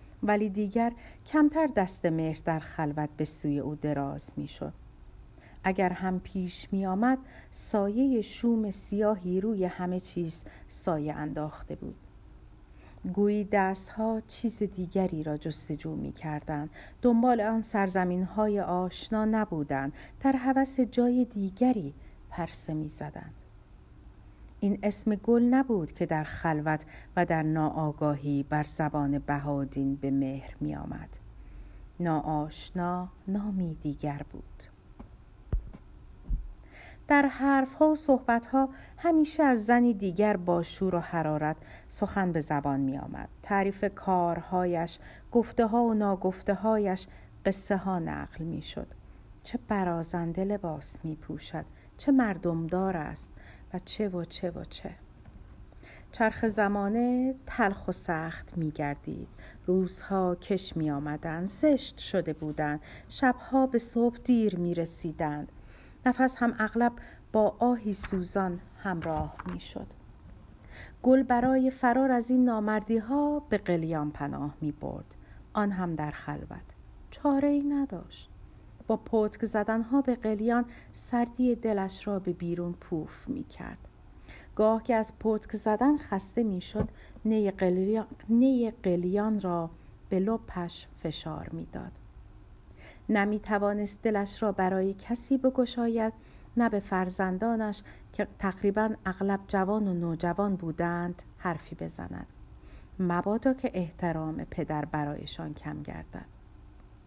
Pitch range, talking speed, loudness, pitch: 160-225 Hz, 120 wpm, -30 LUFS, 190 Hz